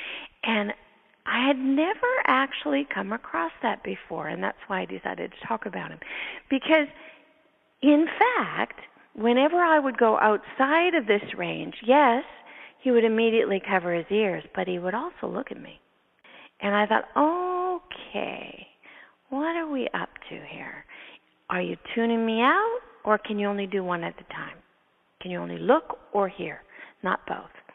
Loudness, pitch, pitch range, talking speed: -25 LUFS, 265 Hz, 210-315 Hz, 160 wpm